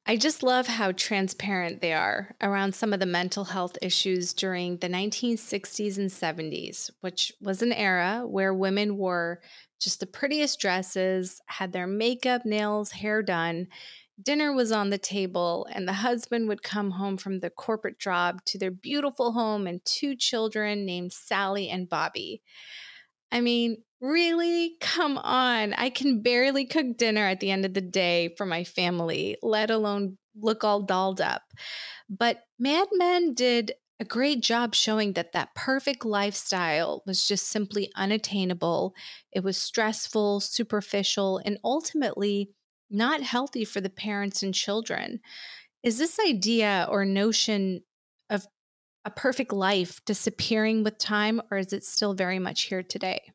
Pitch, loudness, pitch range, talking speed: 205 Hz, -27 LUFS, 190-235 Hz, 155 wpm